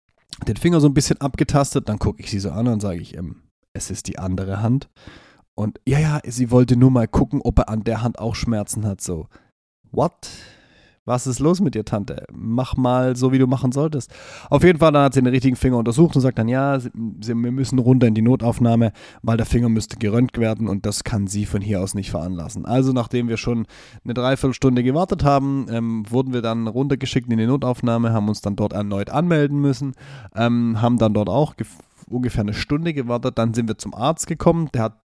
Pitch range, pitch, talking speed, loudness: 110-135 Hz, 120 Hz, 220 wpm, -20 LUFS